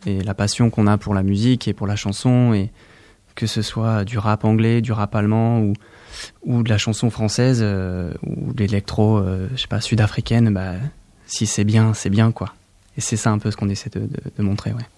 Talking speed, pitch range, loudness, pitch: 230 wpm, 100-115 Hz, -20 LUFS, 110 Hz